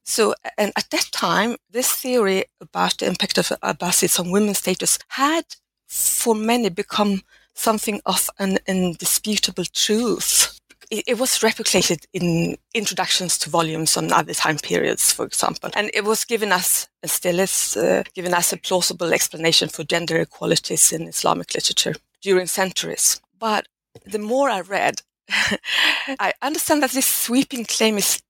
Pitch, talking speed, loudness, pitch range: 205 Hz, 150 wpm, -19 LUFS, 180-230 Hz